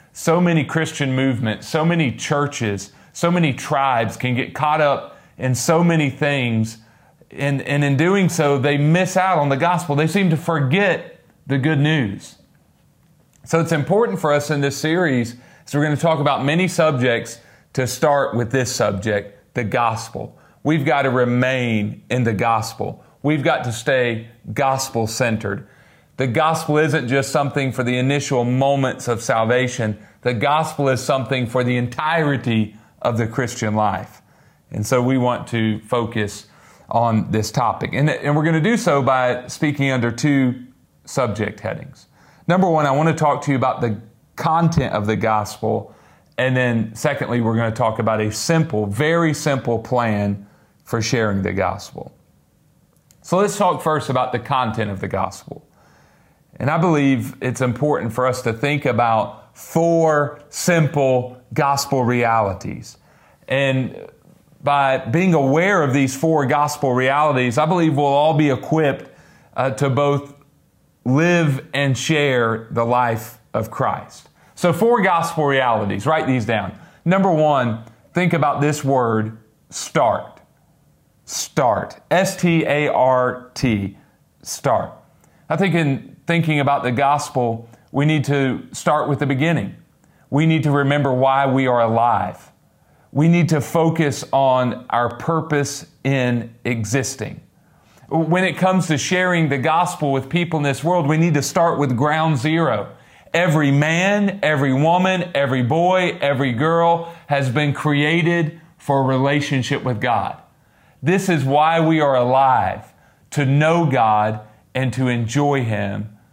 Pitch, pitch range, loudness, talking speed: 140 Hz, 125-155 Hz, -19 LUFS, 155 wpm